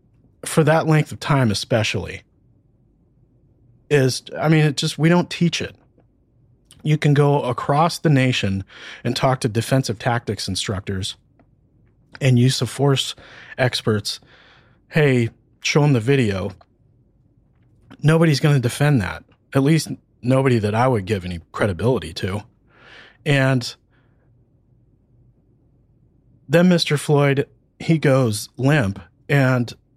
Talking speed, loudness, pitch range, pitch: 120 wpm, -19 LUFS, 115-140 Hz, 130 Hz